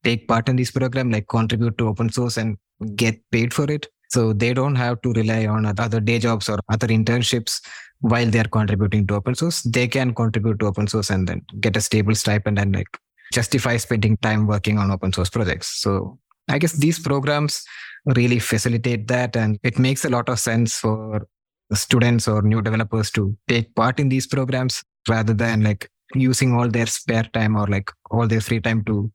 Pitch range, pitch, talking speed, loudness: 110-125 Hz, 115 Hz, 200 wpm, -21 LUFS